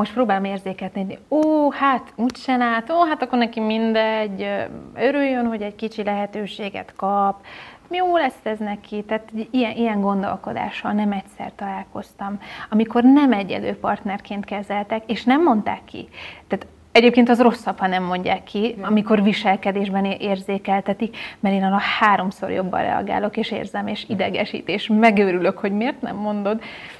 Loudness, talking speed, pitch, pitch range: -21 LUFS, 150 wpm, 210 Hz, 200-235 Hz